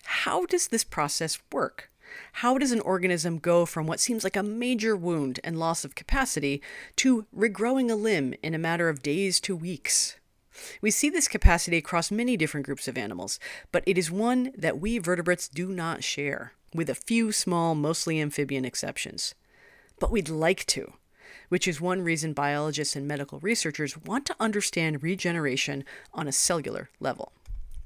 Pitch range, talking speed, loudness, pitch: 155-215 Hz, 170 wpm, -27 LUFS, 175 Hz